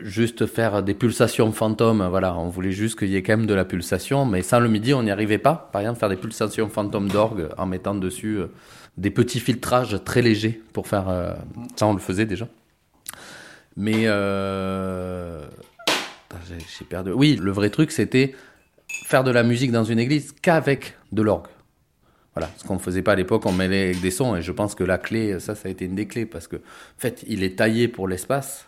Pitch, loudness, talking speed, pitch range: 105 Hz, -22 LUFS, 220 wpm, 95-115 Hz